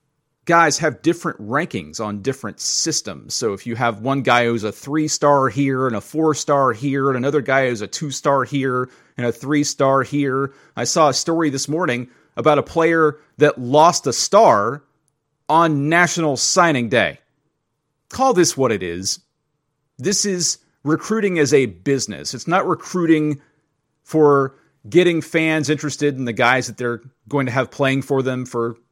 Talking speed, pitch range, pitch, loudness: 170 wpm, 130-155 Hz, 145 Hz, -18 LUFS